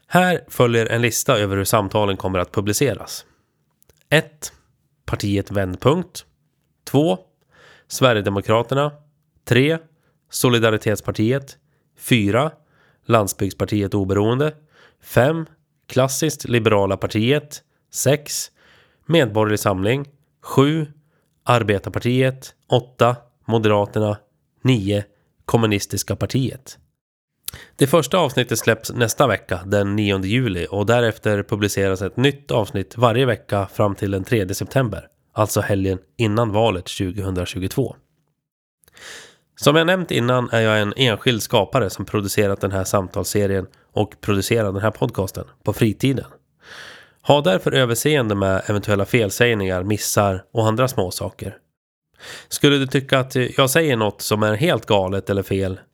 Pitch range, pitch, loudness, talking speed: 100-135 Hz, 115 Hz, -20 LUFS, 115 wpm